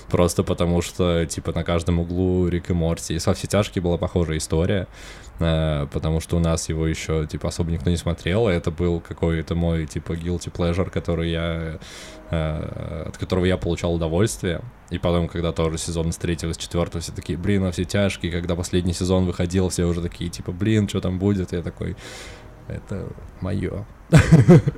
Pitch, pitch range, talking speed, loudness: 90 Hz, 85-95 Hz, 185 wpm, -23 LUFS